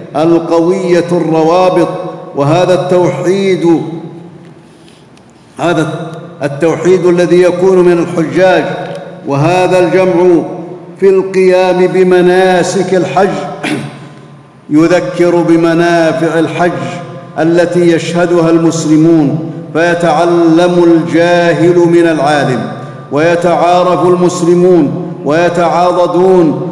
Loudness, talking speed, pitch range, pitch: -9 LUFS, 65 wpm, 165-180 Hz, 175 Hz